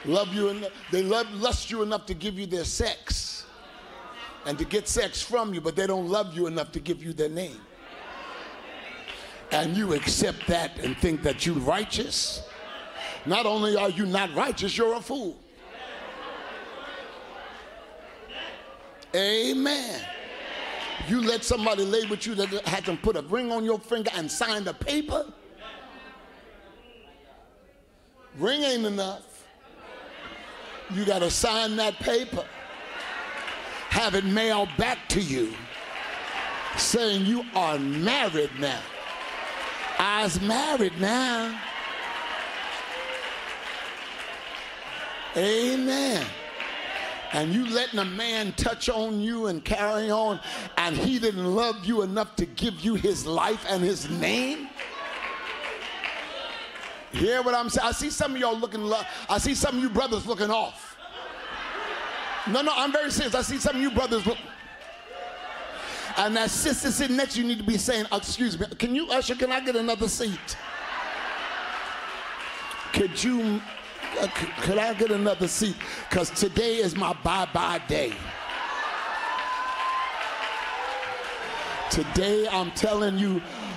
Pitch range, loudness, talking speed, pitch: 195-240 Hz, -27 LUFS, 135 wpm, 215 Hz